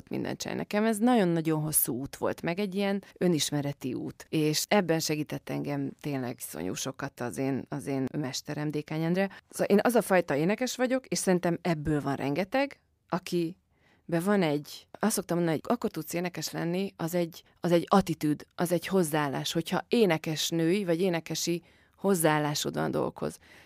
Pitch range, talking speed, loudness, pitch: 150-190 Hz, 160 wpm, -29 LUFS, 165 Hz